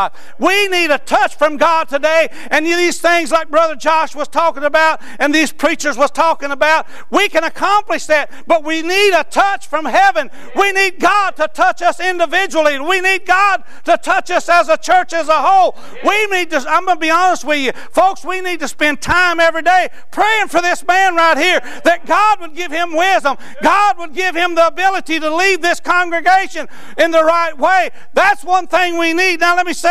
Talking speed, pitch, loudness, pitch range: 210 wpm, 335 Hz, -13 LUFS, 310-360 Hz